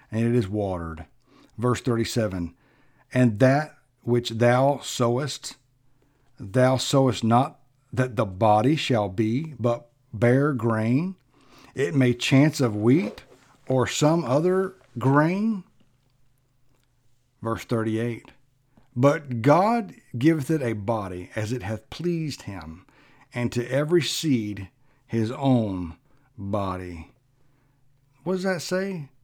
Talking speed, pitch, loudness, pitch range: 115 wpm, 125 Hz, -24 LUFS, 115-140 Hz